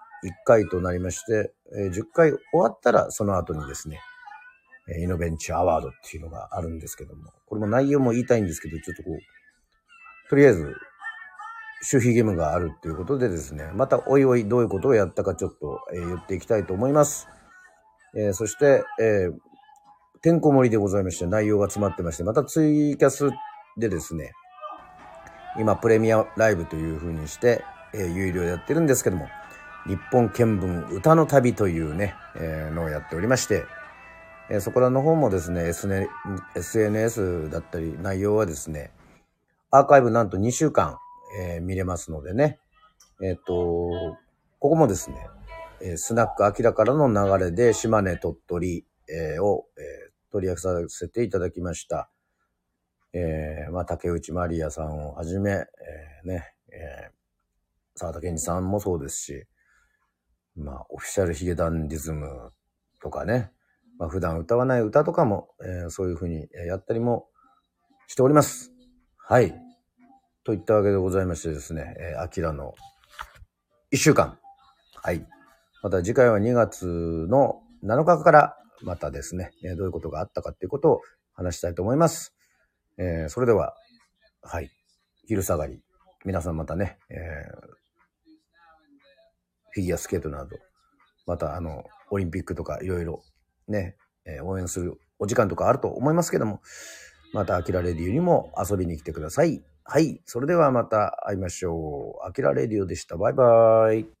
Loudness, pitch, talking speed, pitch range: -24 LUFS, 100 Hz, 330 characters per minute, 85-135 Hz